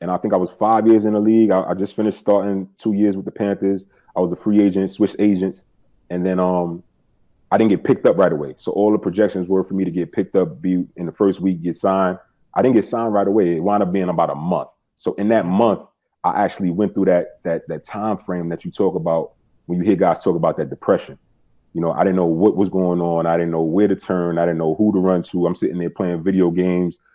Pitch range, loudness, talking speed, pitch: 90-100 Hz, -19 LUFS, 265 wpm, 95 Hz